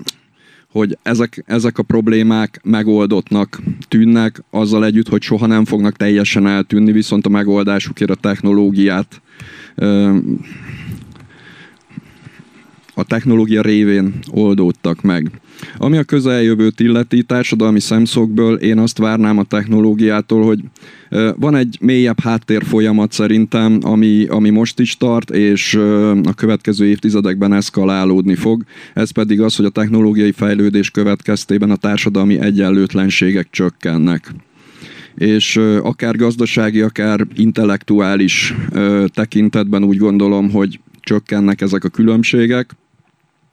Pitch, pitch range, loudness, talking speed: 105 Hz, 100-110 Hz, -13 LUFS, 110 wpm